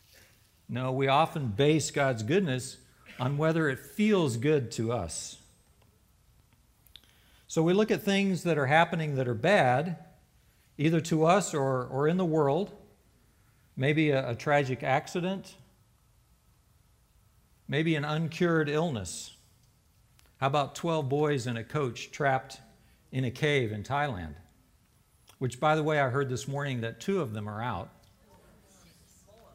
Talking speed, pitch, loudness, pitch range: 140 wpm, 140 Hz, -29 LUFS, 125-160 Hz